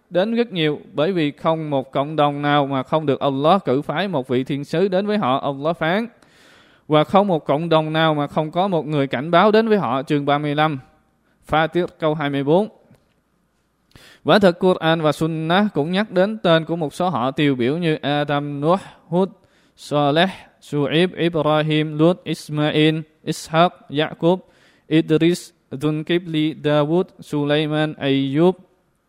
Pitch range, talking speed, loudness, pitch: 145-175 Hz, 165 wpm, -19 LUFS, 155 Hz